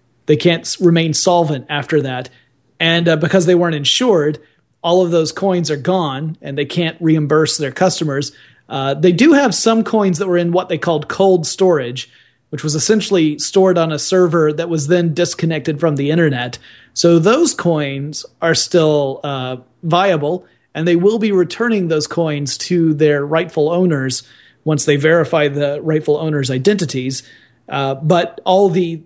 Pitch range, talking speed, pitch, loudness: 145-175 Hz, 165 wpm, 160 Hz, -15 LUFS